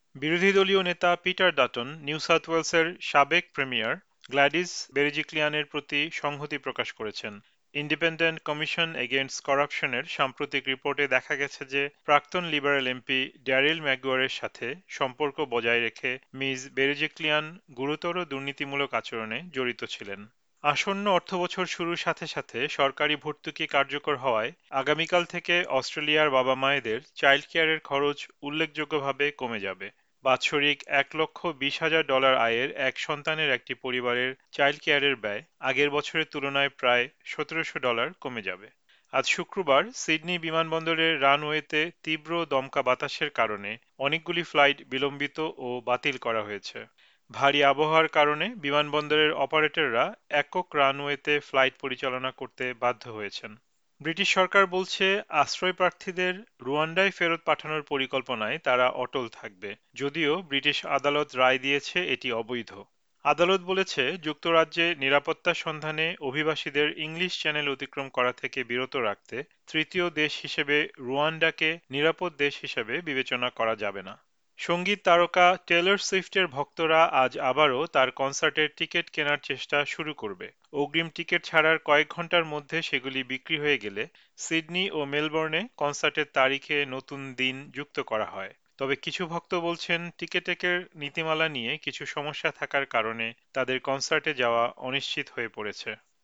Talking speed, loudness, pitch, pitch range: 125 wpm, -26 LUFS, 145 Hz, 135-165 Hz